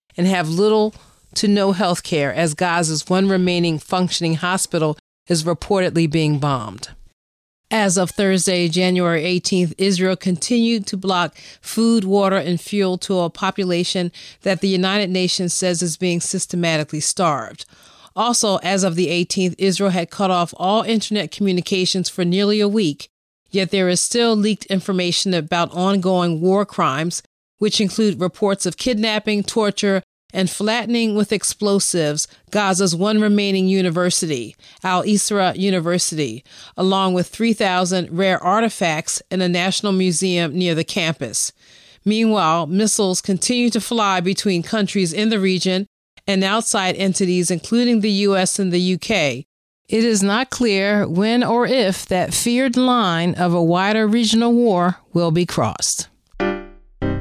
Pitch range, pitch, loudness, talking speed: 175-205 Hz, 190 Hz, -18 LUFS, 140 wpm